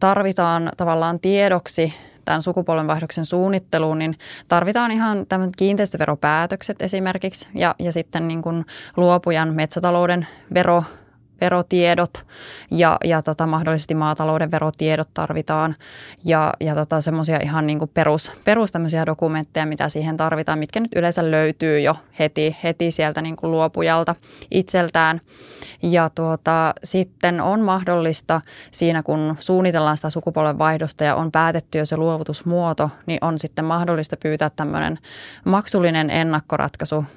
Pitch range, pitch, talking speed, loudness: 155-175 Hz, 160 Hz, 125 wpm, -20 LUFS